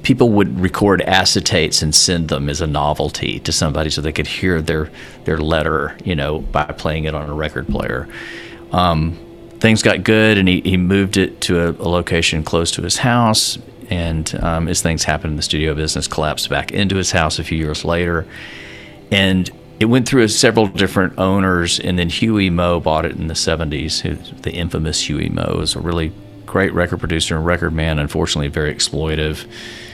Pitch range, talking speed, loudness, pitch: 80-95 Hz, 190 wpm, -16 LUFS, 85 Hz